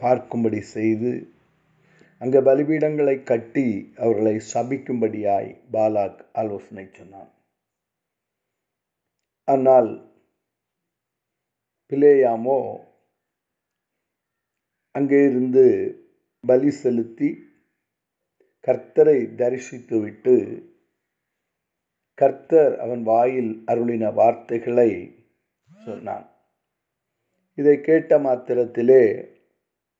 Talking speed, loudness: 55 wpm, -20 LUFS